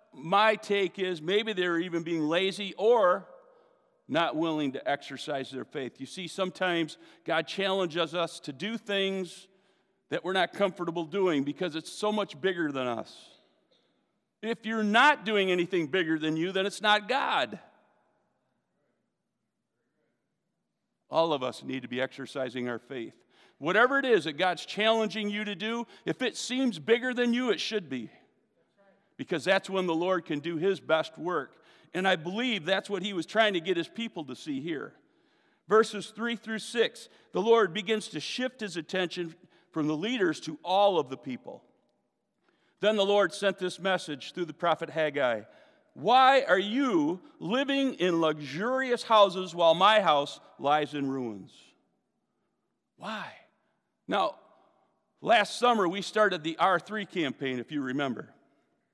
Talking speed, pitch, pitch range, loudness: 155 wpm, 190 Hz, 165-215 Hz, -28 LUFS